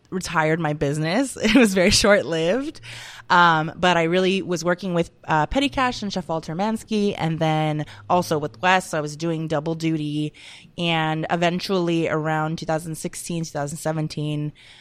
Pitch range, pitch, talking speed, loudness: 155-185 Hz, 165 Hz, 150 wpm, -22 LUFS